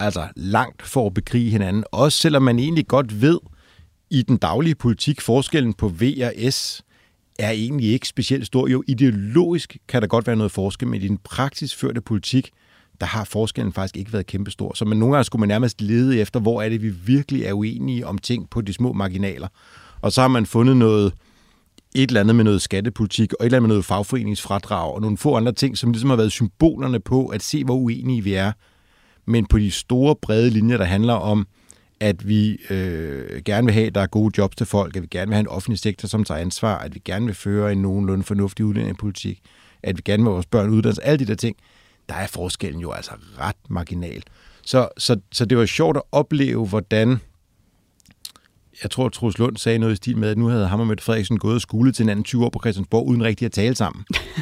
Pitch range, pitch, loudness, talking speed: 100-125 Hz, 110 Hz, -20 LUFS, 230 wpm